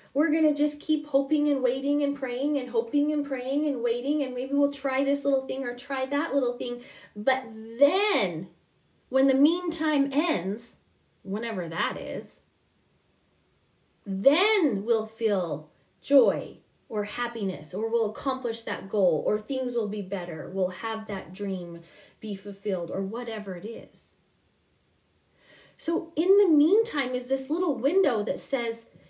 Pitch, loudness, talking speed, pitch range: 260 Hz, -27 LUFS, 150 wpm, 215-285 Hz